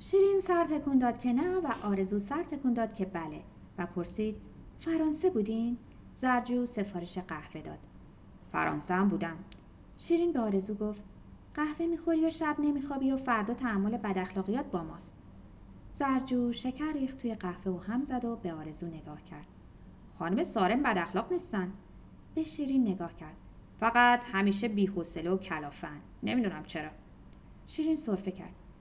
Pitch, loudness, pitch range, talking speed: 225 Hz, -32 LUFS, 180-275 Hz, 150 wpm